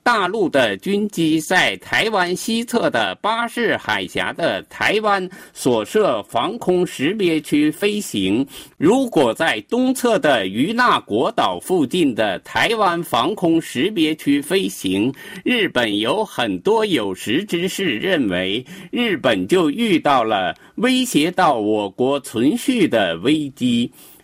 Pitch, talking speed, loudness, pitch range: 205 Hz, 190 characters per minute, -18 LUFS, 170-250 Hz